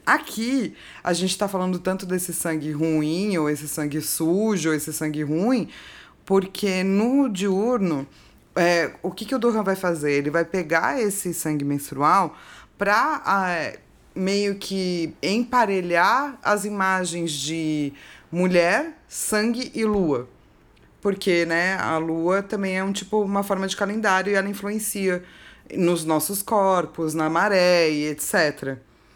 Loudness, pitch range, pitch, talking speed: -23 LUFS, 160-205 Hz, 185 Hz, 140 wpm